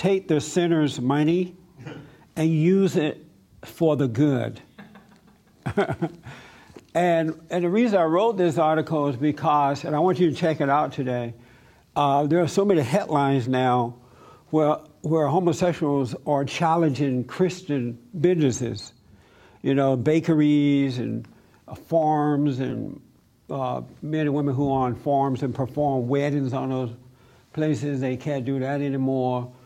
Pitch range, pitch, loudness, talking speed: 130-165 Hz, 145 Hz, -23 LUFS, 140 wpm